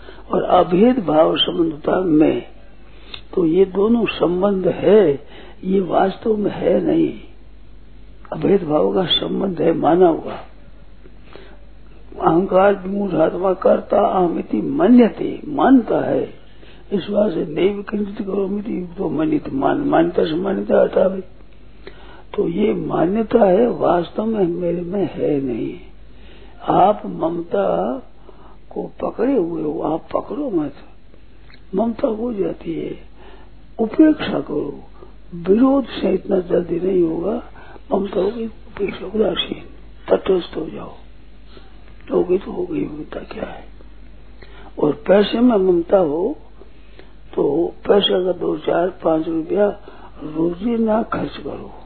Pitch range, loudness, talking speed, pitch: 185-295 Hz, -18 LUFS, 110 wpm, 205 Hz